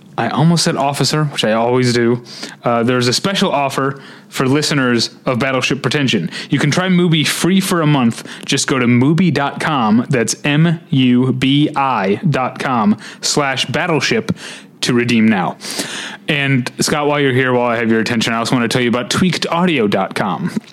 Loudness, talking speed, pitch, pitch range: -15 LUFS, 155 wpm, 140 Hz, 125-170 Hz